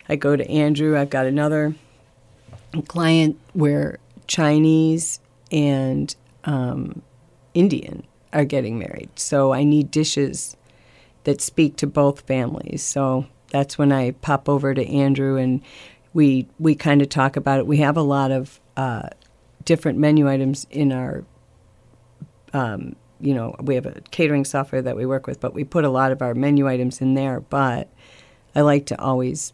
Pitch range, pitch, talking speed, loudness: 130-150 Hz, 140 Hz, 160 wpm, -20 LUFS